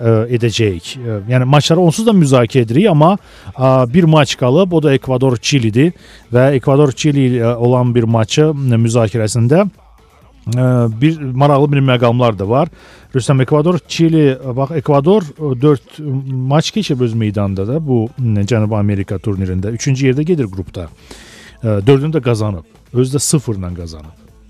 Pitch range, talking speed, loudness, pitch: 115-150 Hz, 125 wpm, -13 LUFS, 130 Hz